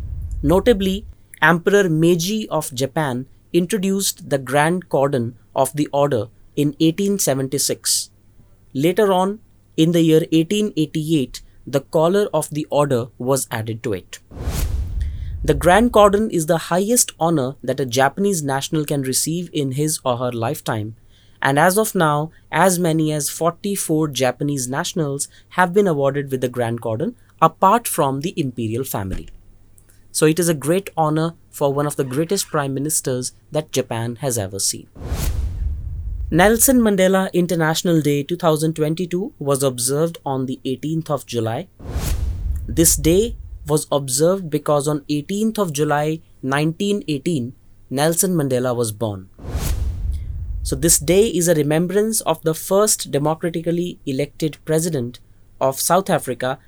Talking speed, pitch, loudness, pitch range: 135 wpm, 145 Hz, -19 LUFS, 120-170 Hz